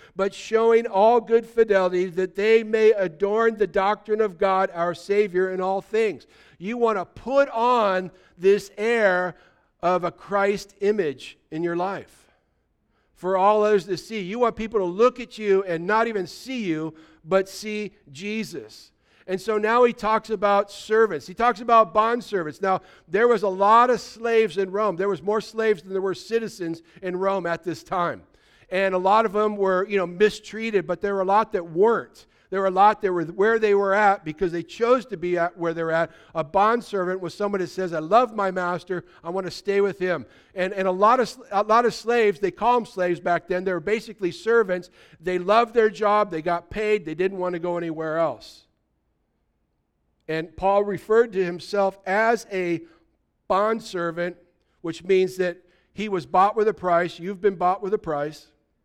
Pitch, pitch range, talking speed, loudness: 195 Hz, 180-215 Hz, 200 wpm, -23 LUFS